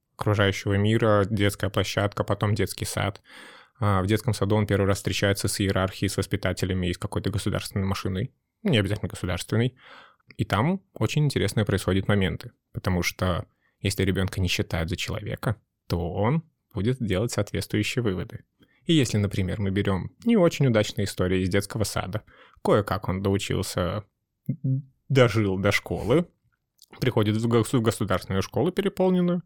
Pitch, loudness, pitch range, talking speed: 105 Hz, -25 LUFS, 95-115 Hz, 140 wpm